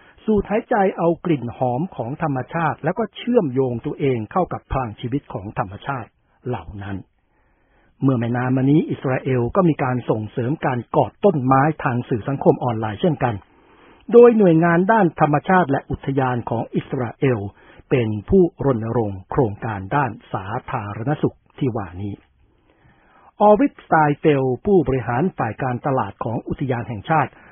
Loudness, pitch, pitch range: -20 LUFS, 135 Hz, 120-160 Hz